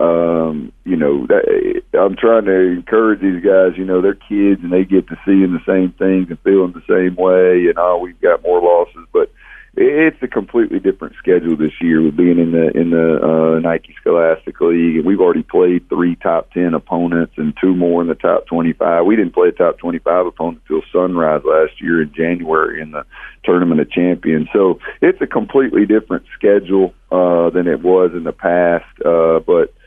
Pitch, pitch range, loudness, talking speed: 90 Hz, 85-105 Hz, -14 LUFS, 205 wpm